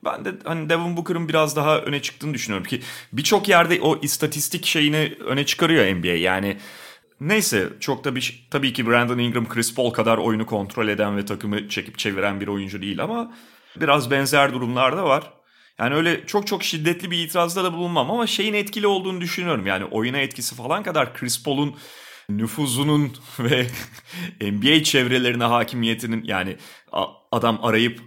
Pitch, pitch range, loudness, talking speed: 135 Hz, 115-165 Hz, -21 LUFS, 160 wpm